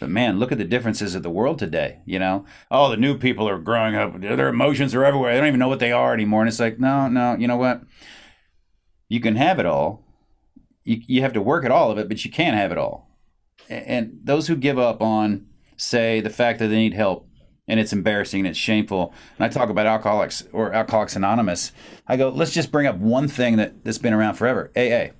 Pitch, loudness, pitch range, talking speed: 110 Hz, -21 LUFS, 105-125 Hz, 240 wpm